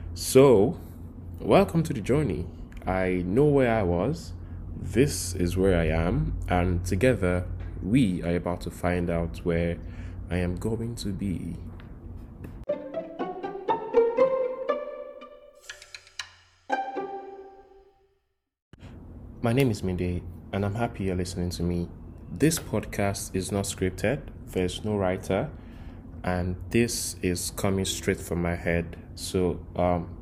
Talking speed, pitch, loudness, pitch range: 115 wpm, 90 Hz, -27 LUFS, 85-120 Hz